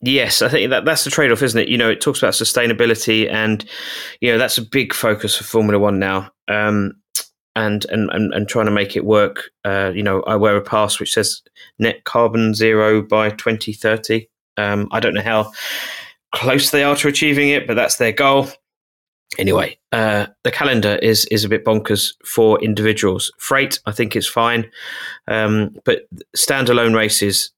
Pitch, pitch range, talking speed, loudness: 110 Hz, 105-115 Hz, 185 wpm, -16 LUFS